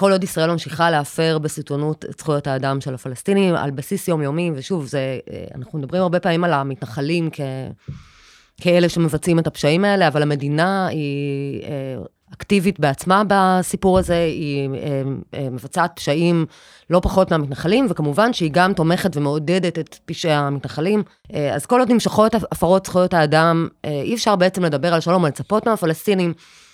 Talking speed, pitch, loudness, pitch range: 145 wpm, 165 Hz, -19 LUFS, 145-185 Hz